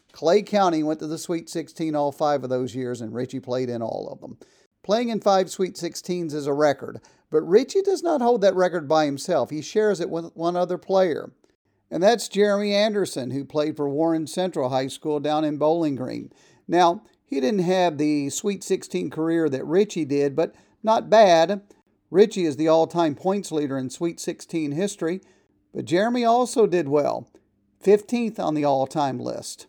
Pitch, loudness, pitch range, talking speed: 165 Hz, -23 LUFS, 150-195 Hz, 190 wpm